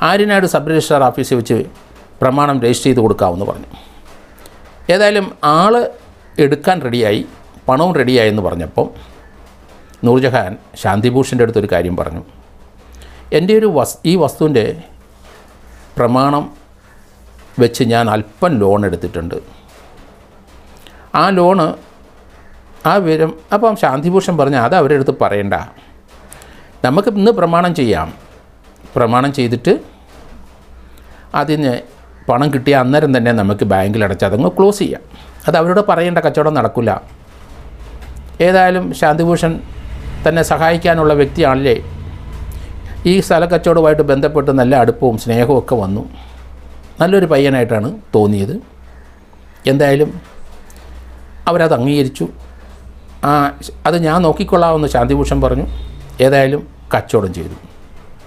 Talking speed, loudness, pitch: 100 wpm, -13 LUFS, 120 Hz